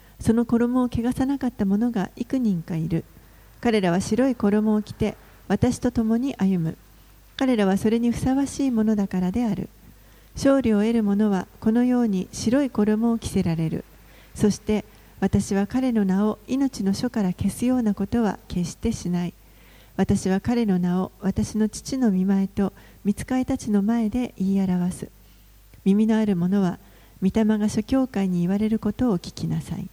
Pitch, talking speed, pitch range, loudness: 210 Hz, 305 characters per minute, 190-235 Hz, -23 LUFS